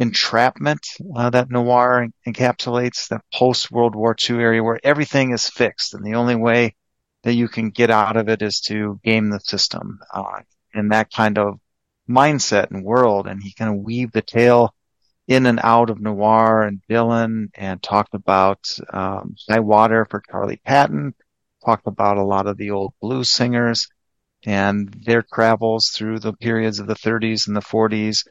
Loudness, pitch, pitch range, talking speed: -18 LUFS, 110 Hz, 105-120 Hz, 180 wpm